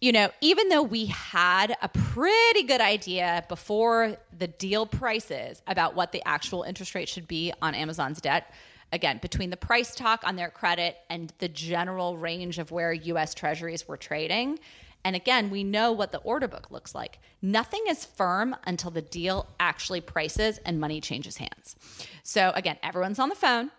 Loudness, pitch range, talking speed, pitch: -27 LUFS, 170-225 Hz, 180 wpm, 185 Hz